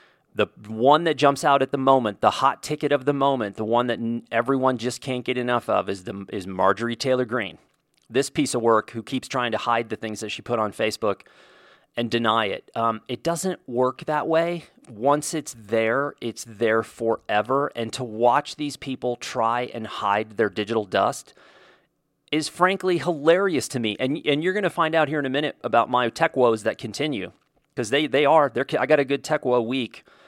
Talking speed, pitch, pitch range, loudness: 205 wpm, 125 Hz, 115-145 Hz, -23 LUFS